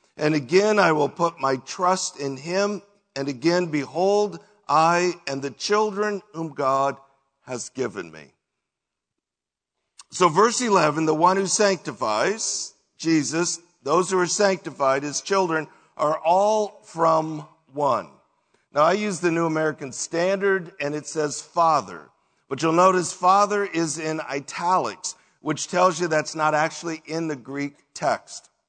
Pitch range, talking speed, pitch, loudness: 150-185 Hz, 140 wpm, 165 Hz, -23 LUFS